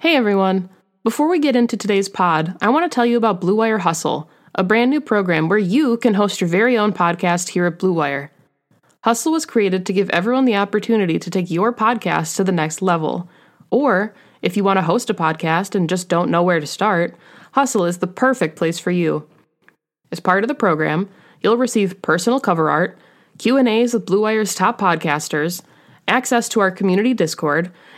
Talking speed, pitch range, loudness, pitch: 195 wpm, 175-225 Hz, -18 LUFS, 195 Hz